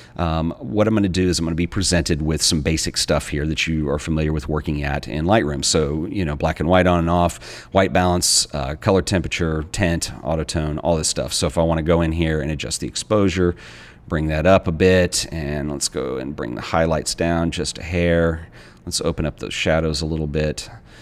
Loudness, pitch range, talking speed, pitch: -20 LUFS, 75-90 Hz, 235 wpm, 80 Hz